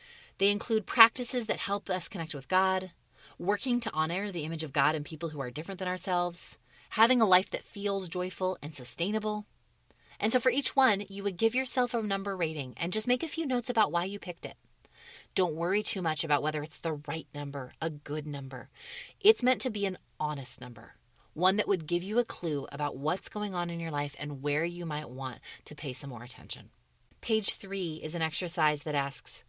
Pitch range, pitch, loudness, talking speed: 150-210 Hz, 175 Hz, -31 LUFS, 215 wpm